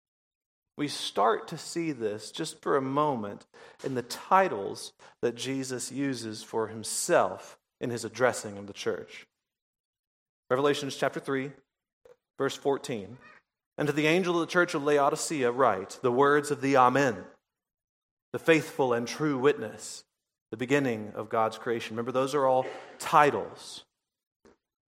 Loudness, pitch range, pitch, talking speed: -28 LUFS, 115-150 Hz, 135 Hz, 140 wpm